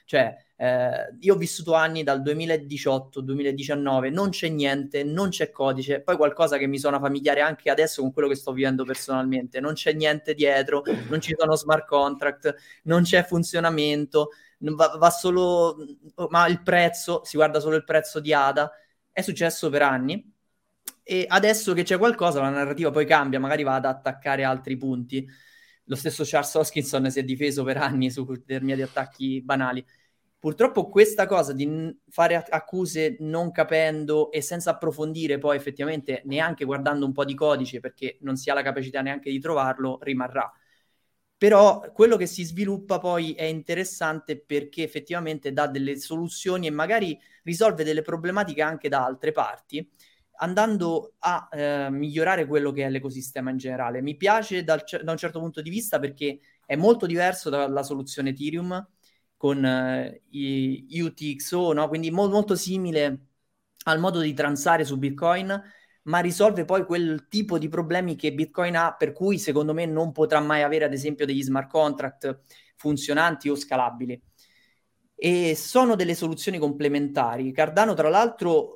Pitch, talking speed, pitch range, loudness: 155 Hz, 165 wpm, 140-170 Hz, -24 LUFS